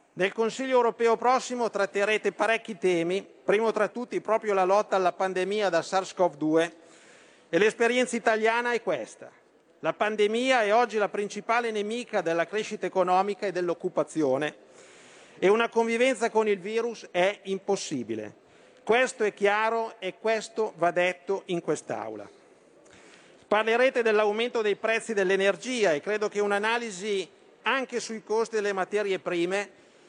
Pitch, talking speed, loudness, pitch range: 210 Hz, 130 wpm, -27 LUFS, 190-225 Hz